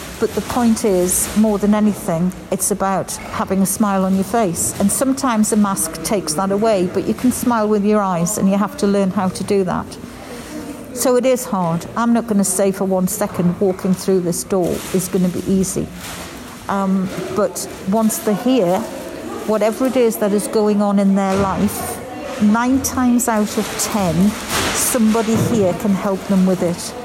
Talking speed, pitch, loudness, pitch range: 190 wpm, 205 Hz, -17 LUFS, 190-225 Hz